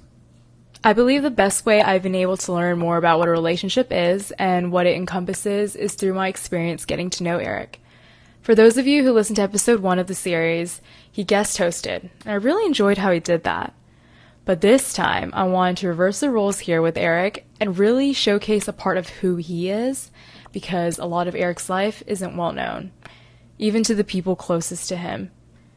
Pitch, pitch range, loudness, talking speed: 190 Hz, 175-210 Hz, -20 LUFS, 205 wpm